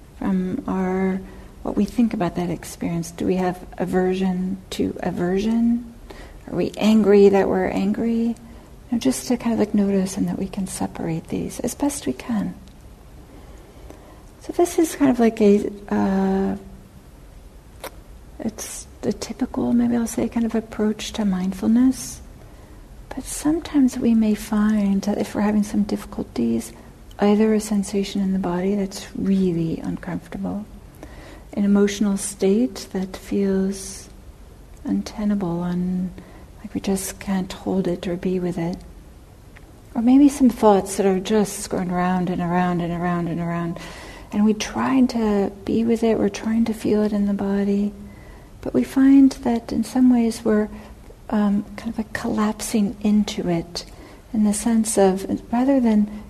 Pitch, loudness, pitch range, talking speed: 205 Hz, -21 LUFS, 185-230 Hz, 150 wpm